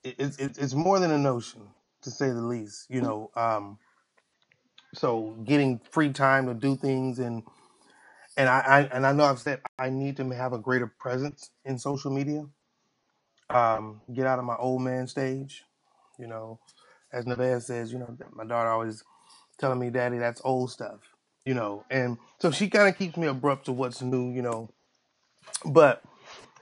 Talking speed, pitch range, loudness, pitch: 180 wpm, 120-135 Hz, -27 LUFS, 130 Hz